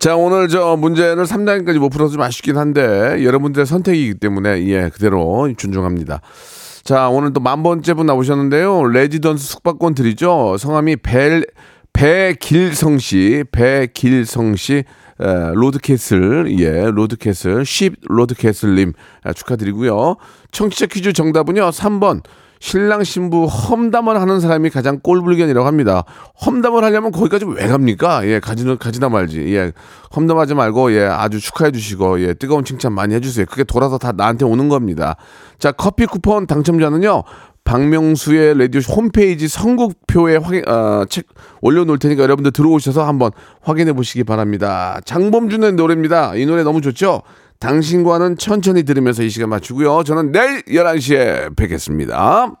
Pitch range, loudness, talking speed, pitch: 115-170 Hz, -14 LUFS, 340 characters per minute, 145 Hz